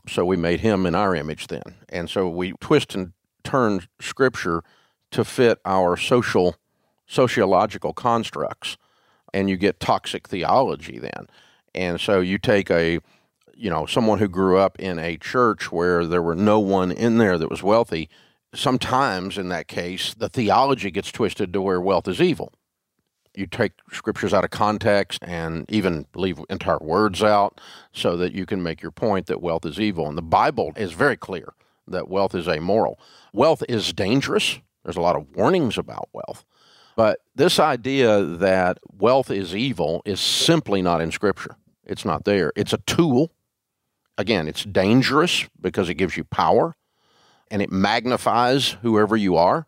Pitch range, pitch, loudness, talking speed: 85-105 Hz, 95 Hz, -21 LUFS, 170 wpm